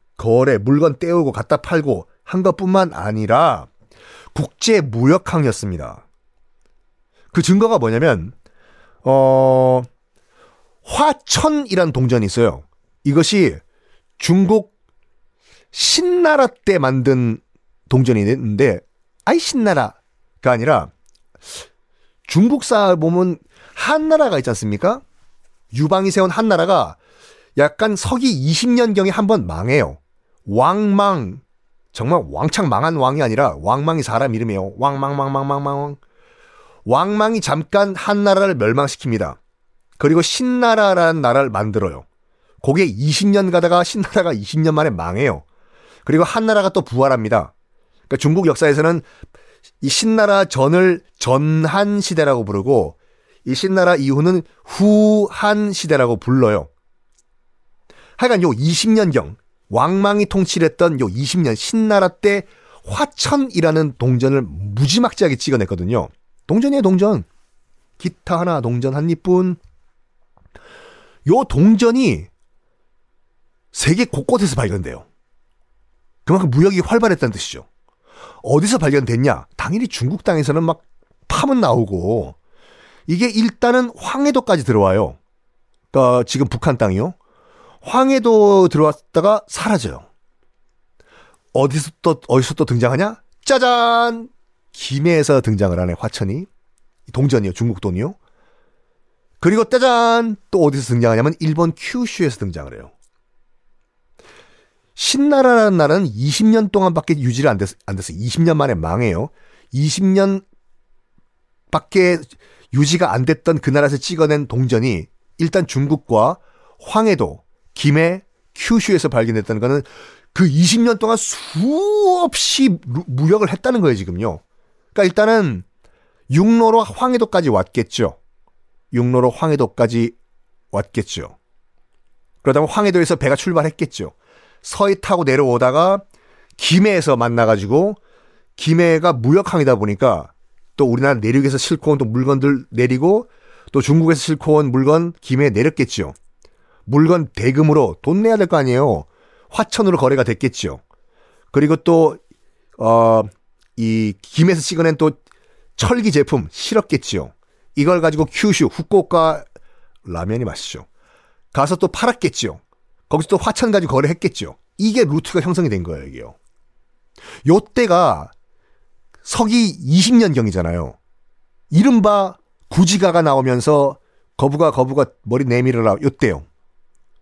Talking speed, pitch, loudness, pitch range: 260 characters per minute, 155 Hz, -16 LUFS, 125-200 Hz